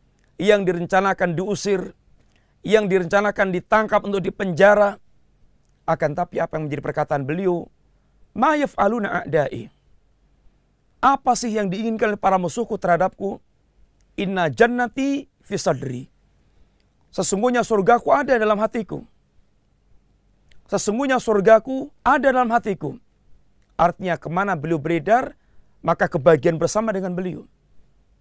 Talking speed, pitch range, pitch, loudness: 100 wpm, 170-220 Hz, 195 Hz, -20 LUFS